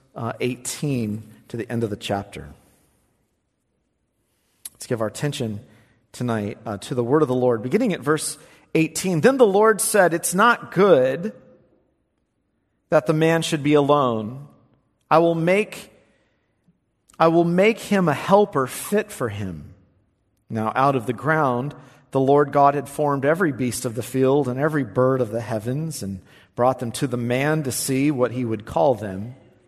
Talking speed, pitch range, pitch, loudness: 170 wpm, 115-155 Hz, 130 Hz, -21 LUFS